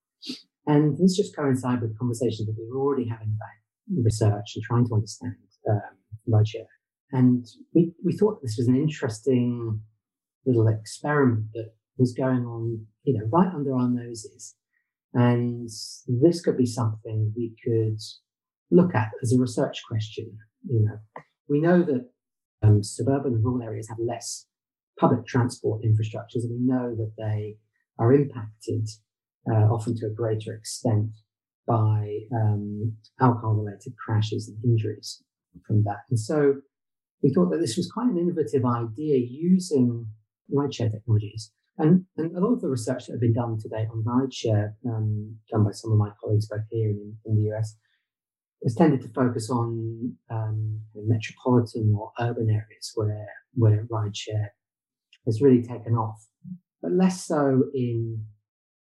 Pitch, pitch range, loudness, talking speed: 115 Hz, 110-130 Hz, -25 LUFS, 155 wpm